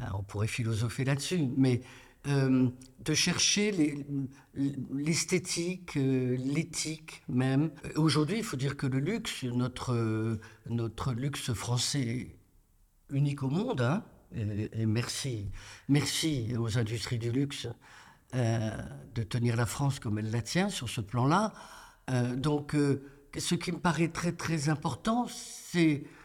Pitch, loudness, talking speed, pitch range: 135 Hz, -31 LUFS, 135 wpm, 120-155 Hz